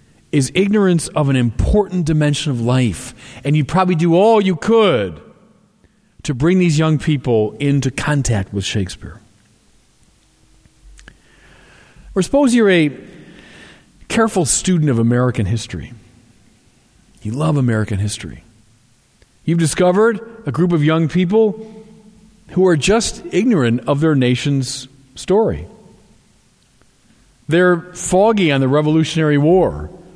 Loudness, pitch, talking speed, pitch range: -16 LUFS, 145 Hz, 115 wpm, 120-180 Hz